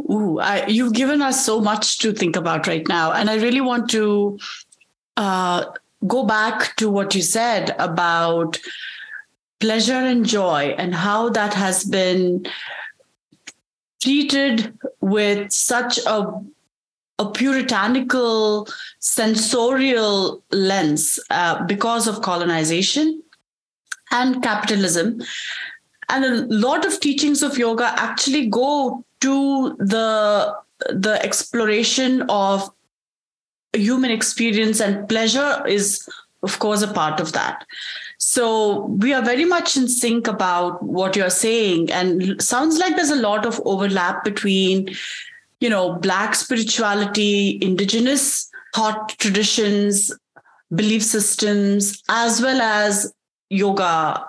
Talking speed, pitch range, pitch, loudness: 115 wpm, 200-255 Hz, 220 Hz, -19 LUFS